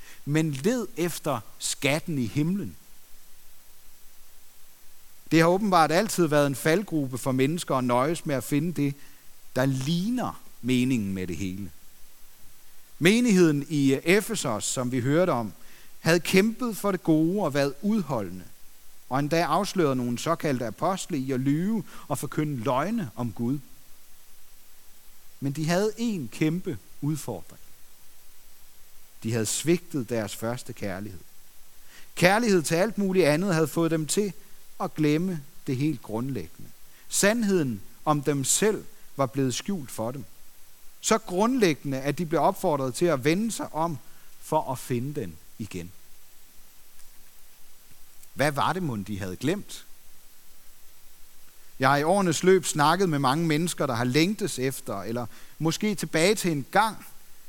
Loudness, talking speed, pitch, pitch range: -26 LUFS, 140 wpm, 150 Hz, 125-175 Hz